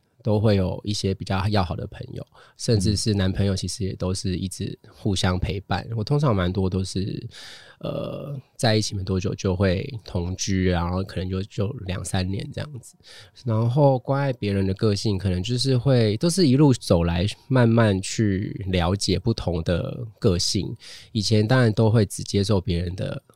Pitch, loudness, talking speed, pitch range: 105 Hz, -23 LUFS, 260 characters per minute, 95-120 Hz